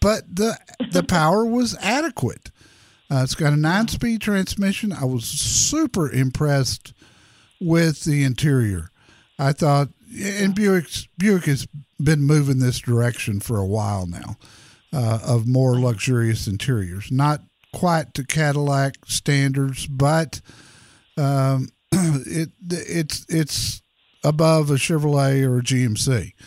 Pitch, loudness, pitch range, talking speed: 140 Hz, -21 LUFS, 120-165 Hz, 125 wpm